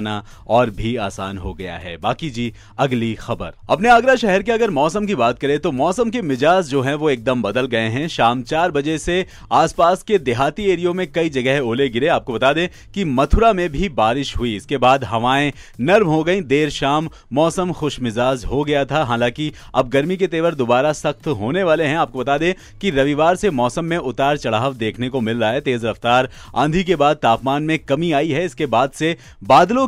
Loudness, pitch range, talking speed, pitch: -18 LUFS, 120-170 Hz, 205 wpm, 140 Hz